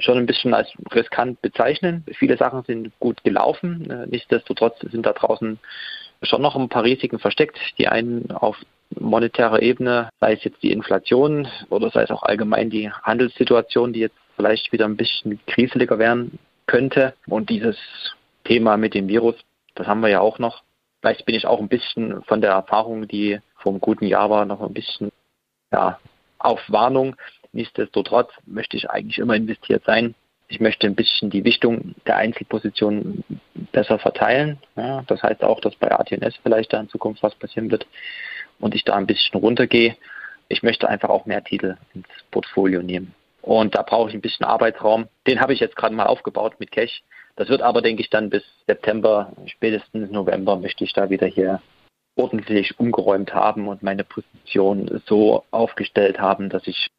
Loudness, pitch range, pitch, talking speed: -20 LUFS, 105-120 Hz, 115 Hz, 175 wpm